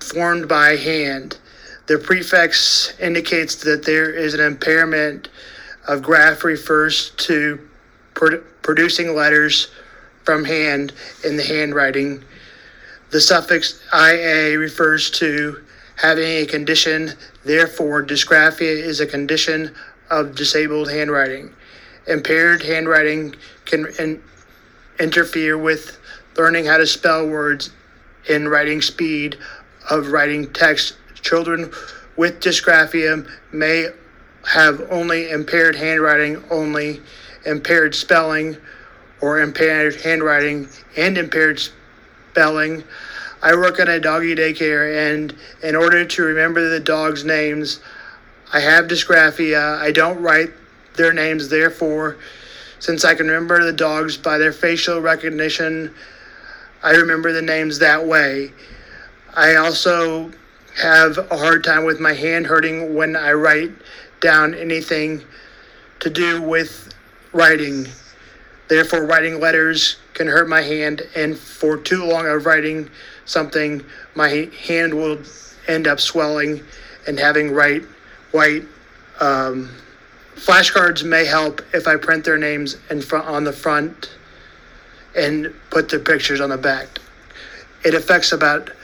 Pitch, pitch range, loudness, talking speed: 155 Hz, 150-165 Hz, -16 LUFS, 120 wpm